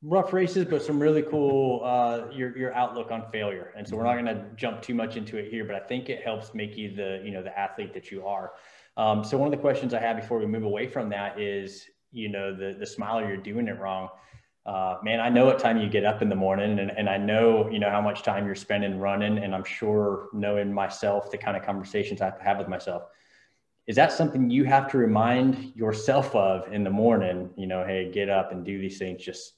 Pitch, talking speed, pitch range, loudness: 105 Hz, 250 wpm, 100-120 Hz, -27 LUFS